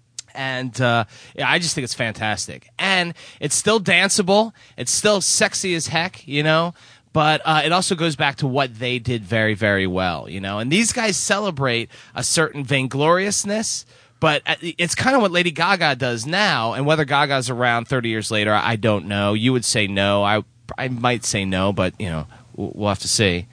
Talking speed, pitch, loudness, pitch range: 195 wpm, 130 Hz, -19 LUFS, 110-165 Hz